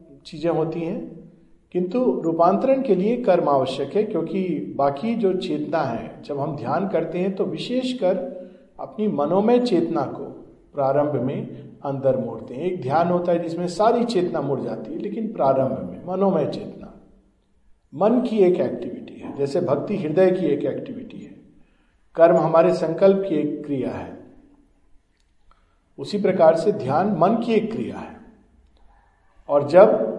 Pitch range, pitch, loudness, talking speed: 150-200 Hz, 175 Hz, -21 LUFS, 150 wpm